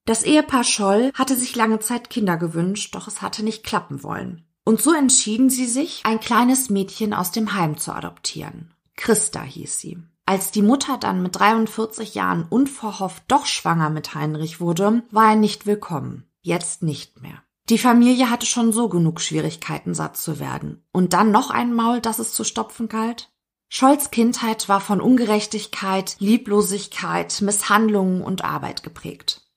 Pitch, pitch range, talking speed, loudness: 210 Hz, 180-230 Hz, 165 wpm, -20 LUFS